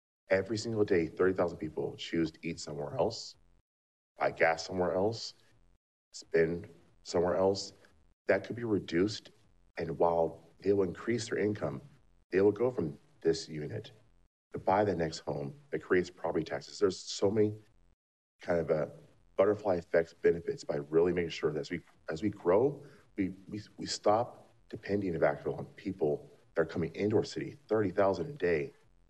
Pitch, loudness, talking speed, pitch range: 95 Hz, -33 LUFS, 165 wpm, 80-105 Hz